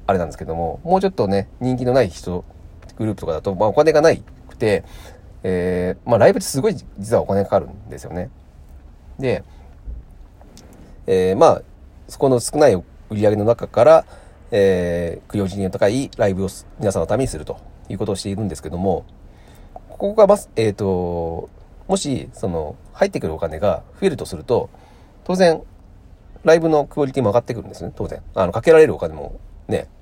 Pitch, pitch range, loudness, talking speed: 95 Hz, 85-120 Hz, -19 LUFS, 360 characters per minute